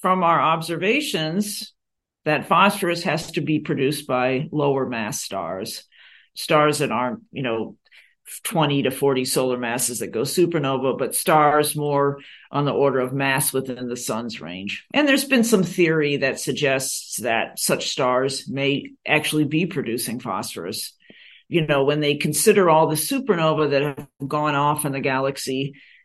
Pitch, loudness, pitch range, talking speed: 145 Hz, -21 LUFS, 135-165 Hz, 155 wpm